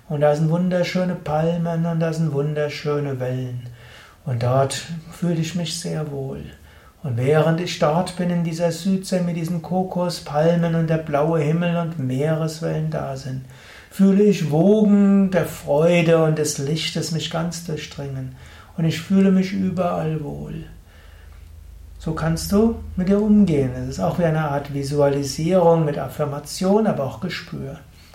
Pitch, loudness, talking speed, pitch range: 160 Hz, -21 LUFS, 150 wpm, 140-175 Hz